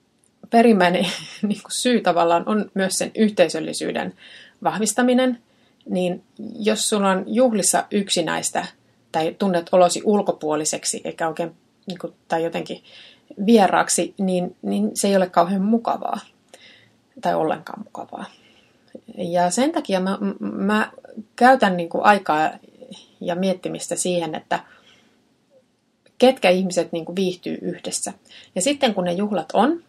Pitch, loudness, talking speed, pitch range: 195 Hz, -21 LUFS, 110 wpm, 180-235 Hz